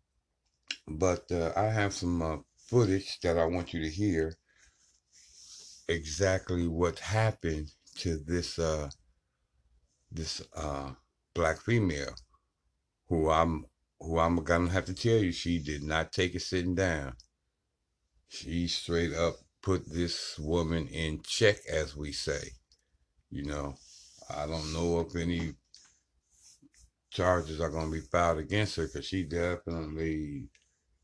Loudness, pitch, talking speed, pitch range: -32 LUFS, 80 Hz, 130 wpm, 75-90 Hz